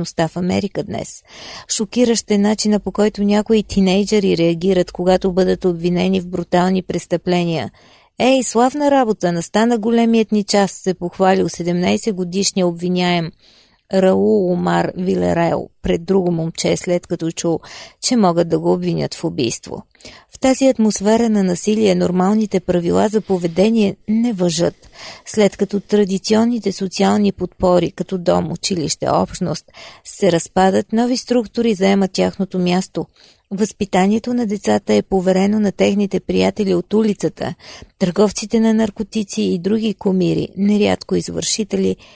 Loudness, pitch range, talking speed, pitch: -17 LUFS, 180-215 Hz, 125 wpm, 190 Hz